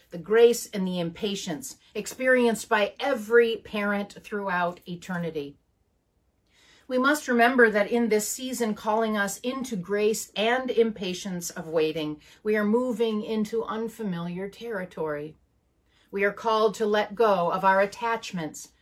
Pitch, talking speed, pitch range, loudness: 210 Hz, 130 wpm, 180-230 Hz, -26 LUFS